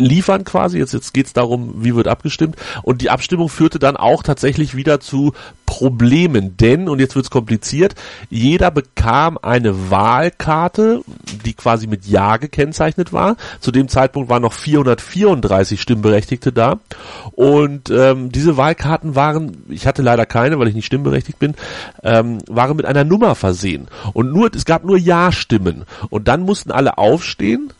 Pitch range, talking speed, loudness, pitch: 115-155 Hz, 160 wpm, -15 LUFS, 130 Hz